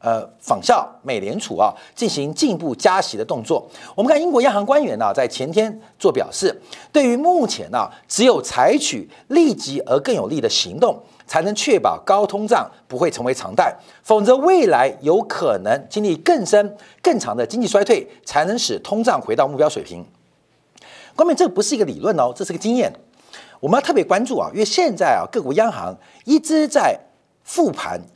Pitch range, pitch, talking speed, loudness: 210-340 Hz, 280 Hz, 285 characters per minute, -18 LUFS